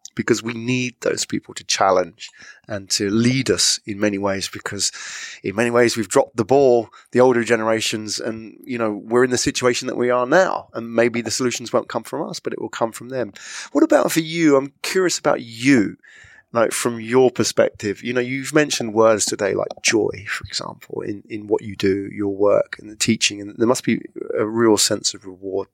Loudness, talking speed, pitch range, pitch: -20 LUFS, 210 wpm, 105-125 Hz, 115 Hz